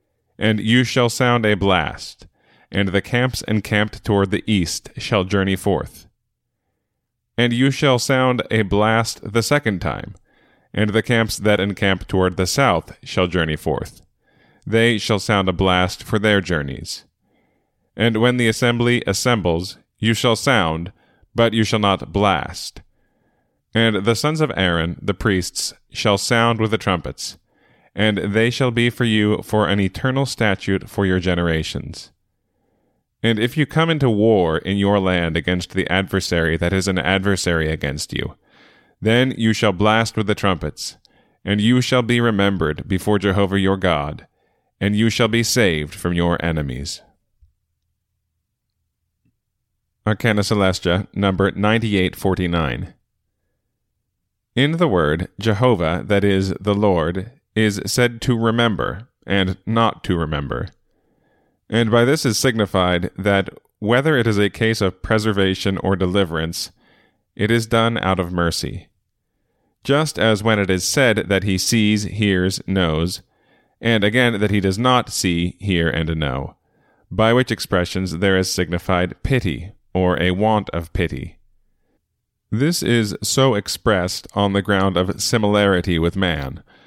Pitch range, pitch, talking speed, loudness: 90-115 Hz, 100 Hz, 145 wpm, -19 LUFS